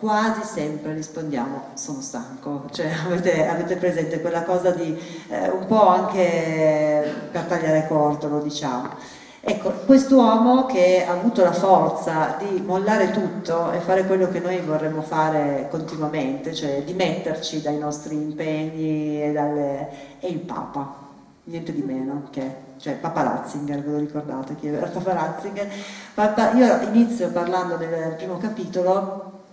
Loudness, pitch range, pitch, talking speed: -22 LUFS, 150-185 Hz, 165 Hz, 140 wpm